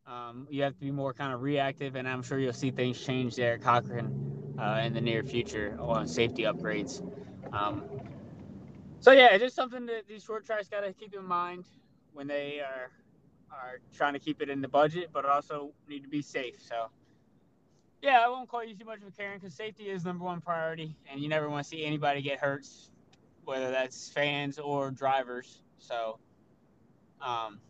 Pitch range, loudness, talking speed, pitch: 125-175 Hz, -30 LUFS, 200 wpm, 140 Hz